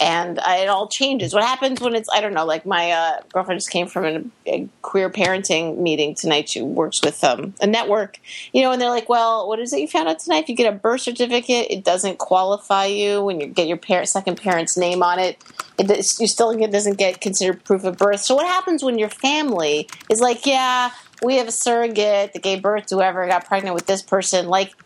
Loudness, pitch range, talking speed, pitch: -19 LUFS, 185-235 Hz, 240 wpm, 200 Hz